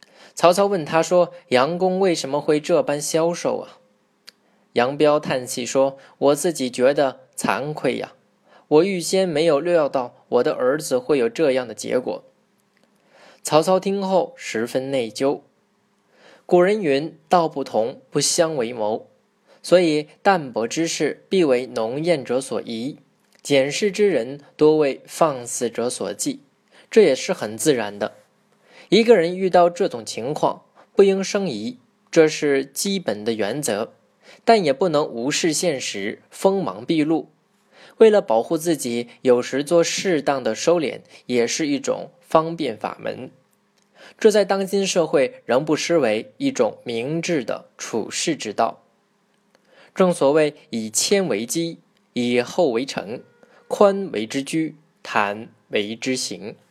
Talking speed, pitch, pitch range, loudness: 200 characters per minute, 165 Hz, 135-195 Hz, -21 LUFS